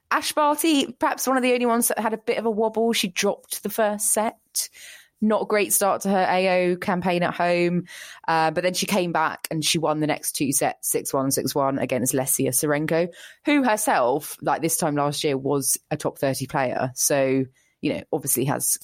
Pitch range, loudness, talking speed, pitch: 150-220 Hz, -23 LUFS, 210 wpm, 180 Hz